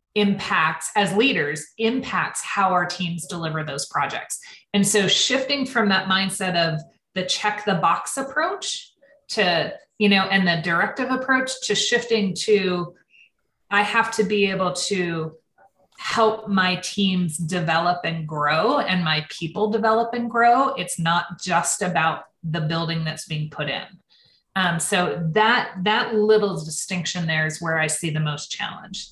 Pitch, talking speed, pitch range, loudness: 190 Hz, 150 wpm, 170-215 Hz, -22 LUFS